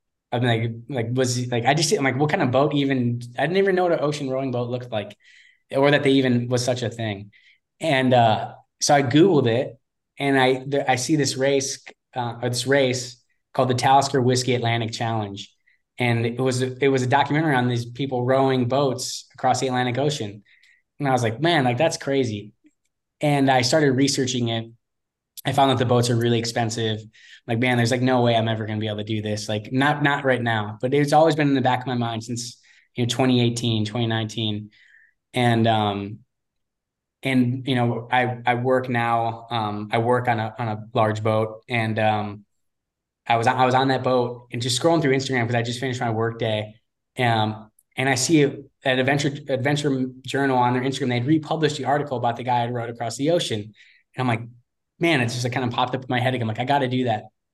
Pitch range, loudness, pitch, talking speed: 115-135 Hz, -22 LUFS, 125 Hz, 220 wpm